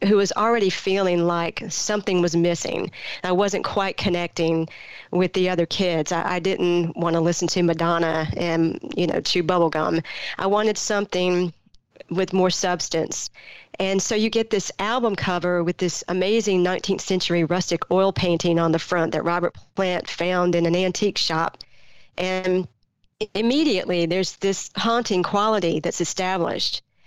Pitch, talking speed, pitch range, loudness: 180 Hz, 155 wpm, 170-195 Hz, -22 LUFS